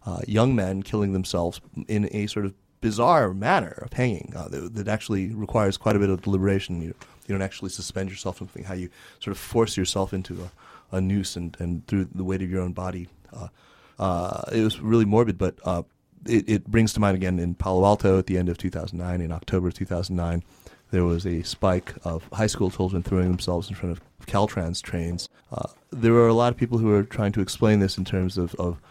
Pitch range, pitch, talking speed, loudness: 90-105 Hz, 95 Hz, 220 wpm, -25 LUFS